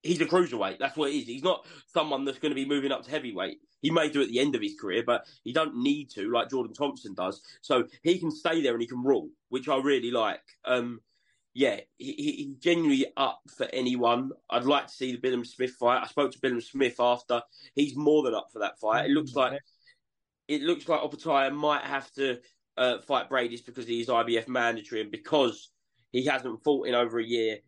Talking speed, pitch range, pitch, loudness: 230 wpm, 125-155 Hz, 135 Hz, -29 LUFS